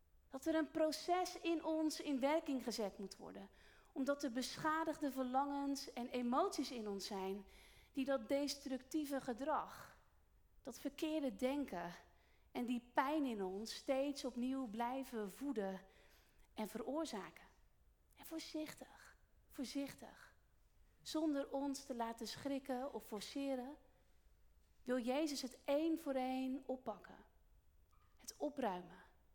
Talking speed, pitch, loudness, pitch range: 115 wpm, 270 Hz, -43 LUFS, 240-295 Hz